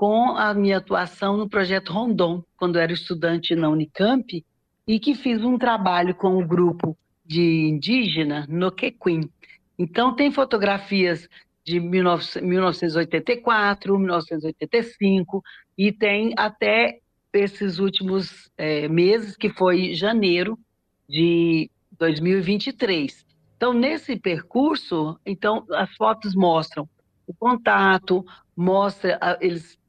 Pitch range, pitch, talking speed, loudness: 170-210 Hz, 185 Hz, 110 wpm, -22 LUFS